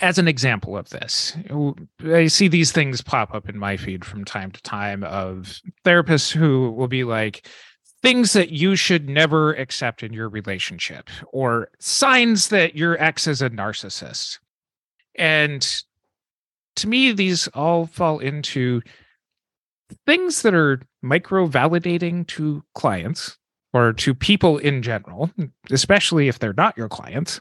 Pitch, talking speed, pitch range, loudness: 150 Hz, 145 wpm, 115-175 Hz, -19 LUFS